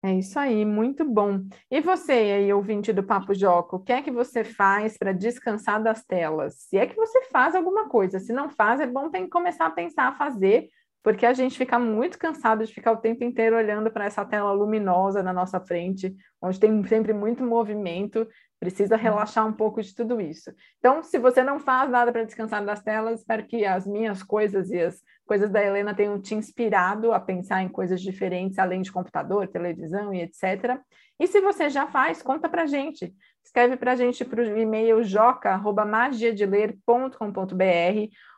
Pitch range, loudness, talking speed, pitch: 200-245 Hz, -24 LUFS, 190 wpm, 220 Hz